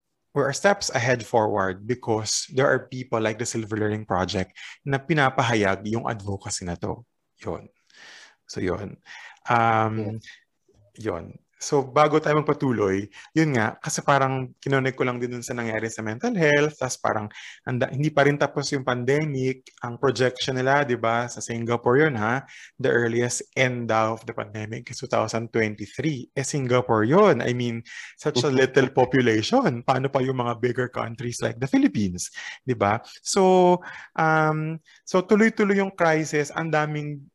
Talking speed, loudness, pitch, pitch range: 155 wpm, -24 LUFS, 125 Hz, 115-145 Hz